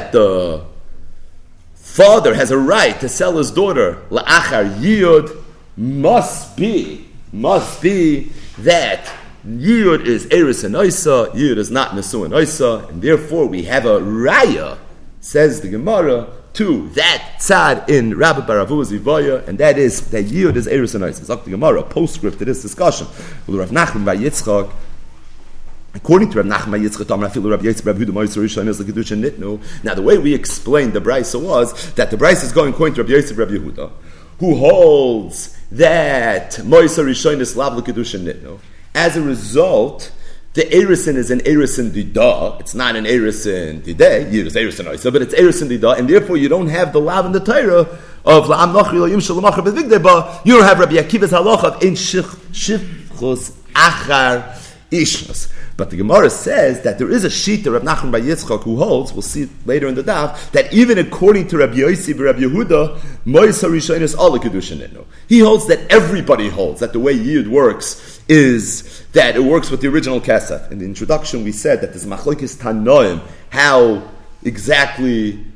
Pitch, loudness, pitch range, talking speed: 135 Hz, -14 LUFS, 105-170 Hz, 170 wpm